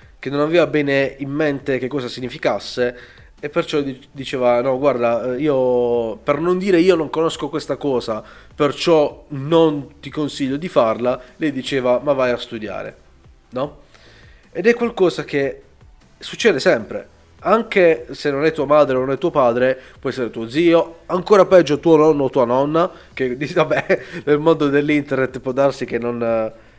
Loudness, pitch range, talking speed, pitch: -18 LUFS, 130-155 Hz, 165 wpm, 140 Hz